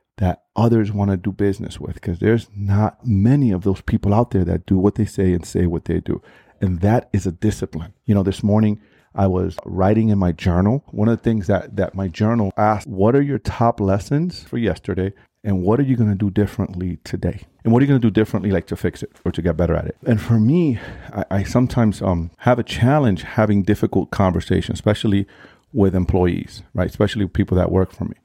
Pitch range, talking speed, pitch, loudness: 95-110 Hz, 225 wpm, 100 Hz, -19 LUFS